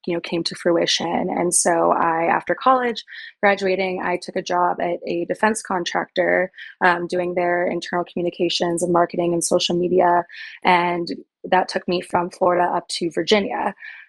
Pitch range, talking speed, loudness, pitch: 175-185 Hz, 160 wpm, -20 LUFS, 175 Hz